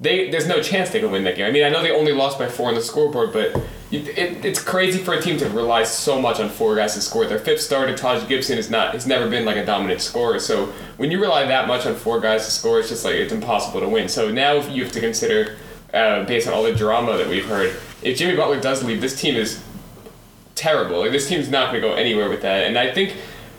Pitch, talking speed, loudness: 145 Hz, 265 wpm, -20 LUFS